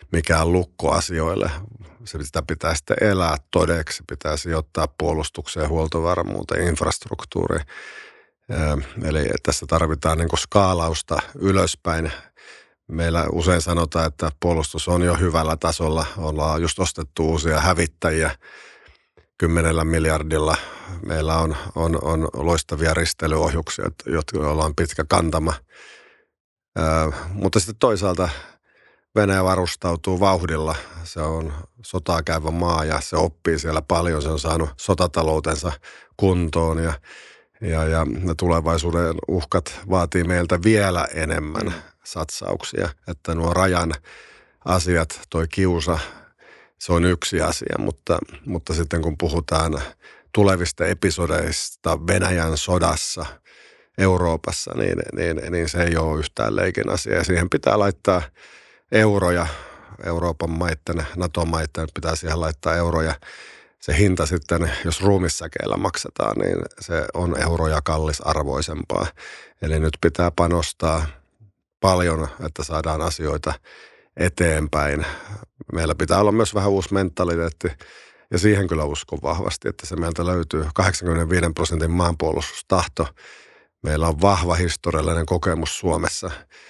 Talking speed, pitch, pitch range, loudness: 115 wpm, 85 Hz, 80-90 Hz, -22 LUFS